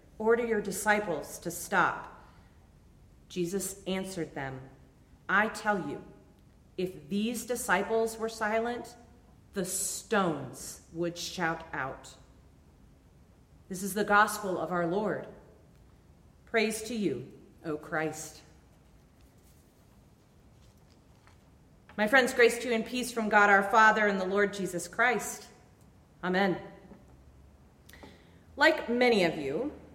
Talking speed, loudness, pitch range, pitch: 110 wpm, -29 LUFS, 160-220 Hz, 195 Hz